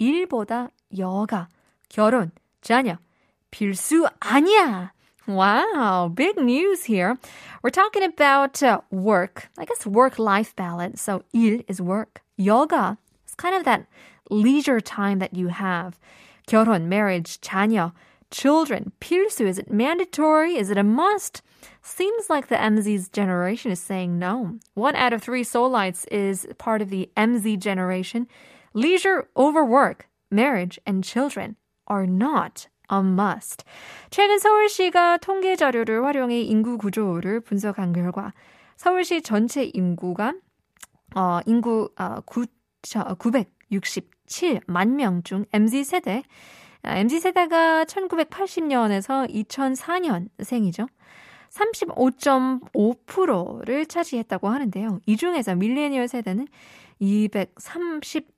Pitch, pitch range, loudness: 230 Hz, 200-285 Hz, -22 LUFS